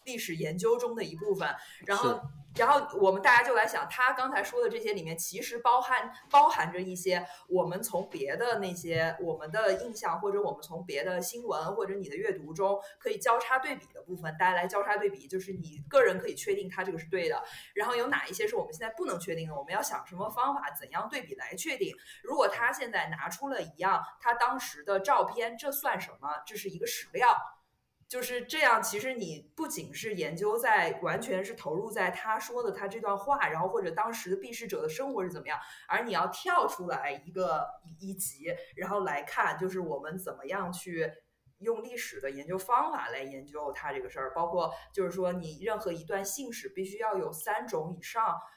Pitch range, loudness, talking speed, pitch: 180-260 Hz, -31 LUFS, 315 characters per minute, 205 Hz